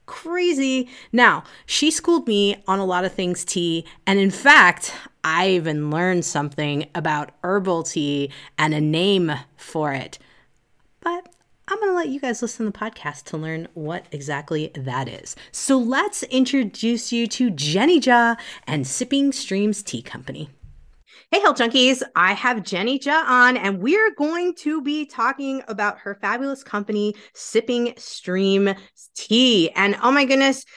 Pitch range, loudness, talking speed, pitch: 170-265 Hz, -20 LUFS, 160 wpm, 210 Hz